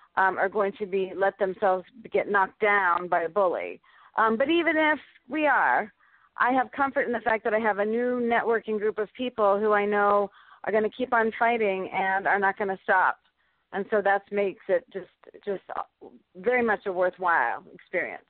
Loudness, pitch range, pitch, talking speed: -25 LUFS, 195-240 Hz, 210 Hz, 200 wpm